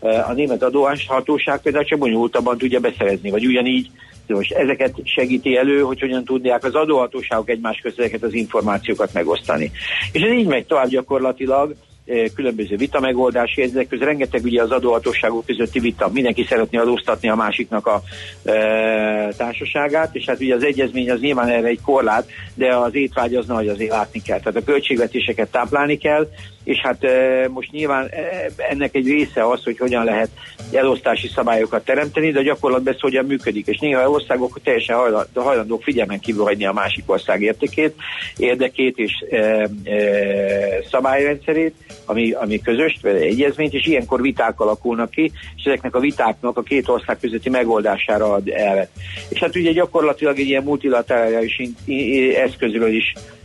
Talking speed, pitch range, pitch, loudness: 160 wpm, 115-140 Hz, 125 Hz, -18 LUFS